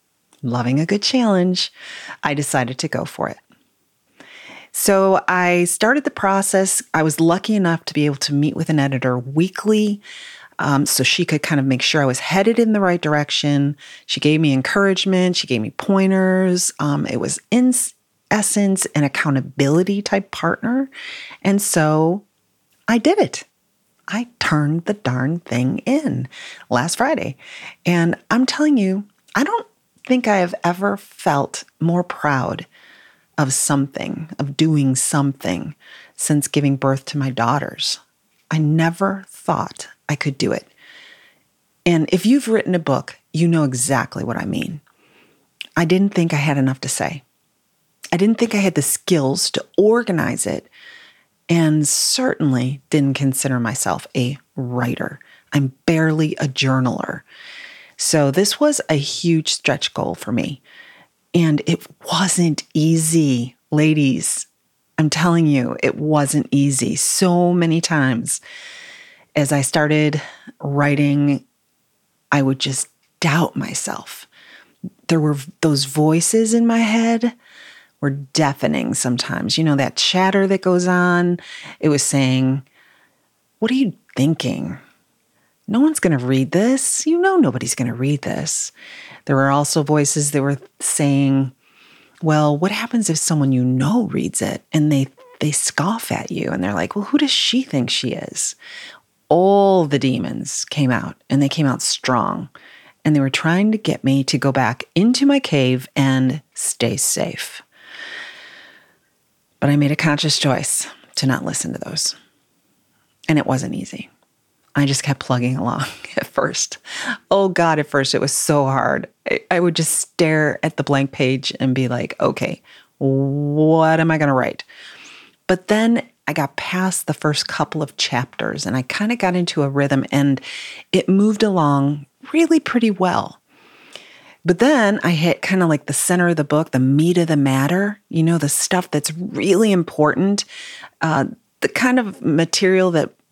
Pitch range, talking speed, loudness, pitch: 140-195 Hz, 155 wpm, -18 LUFS, 160 Hz